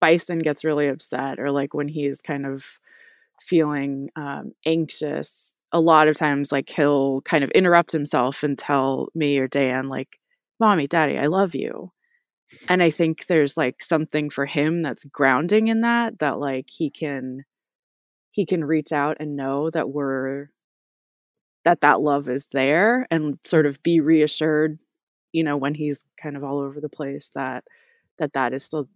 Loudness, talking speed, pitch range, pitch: -22 LUFS, 170 wpm, 140-165 Hz, 150 Hz